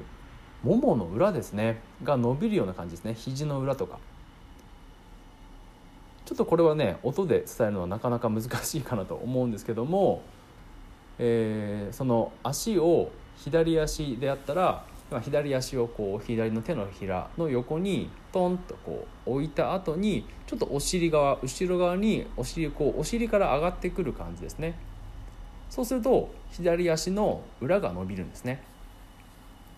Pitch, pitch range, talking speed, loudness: 125 Hz, 100-165 Hz, 290 characters per minute, -28 LUFS